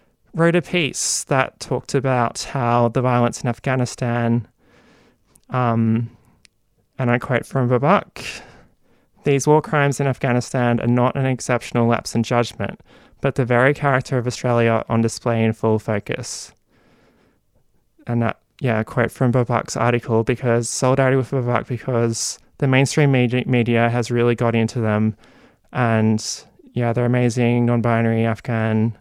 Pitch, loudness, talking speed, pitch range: 120 Hz, -19 LUFS, 140 wpm, 115-130 Hz